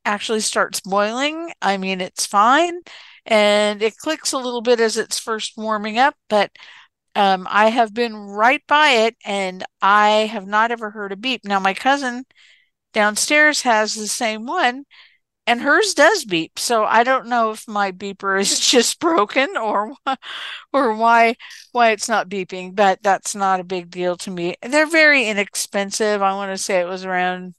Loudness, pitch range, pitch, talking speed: -18 LUFS, 200-250 Hz, 215 Hz, 175 wpm